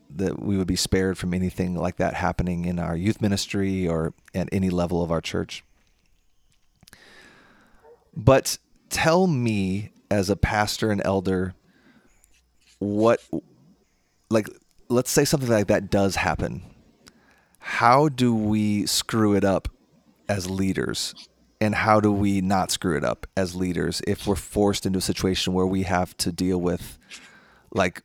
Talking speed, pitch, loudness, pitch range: 150 wpm, 95 Hz, -24 LUFS, 90-105 Hz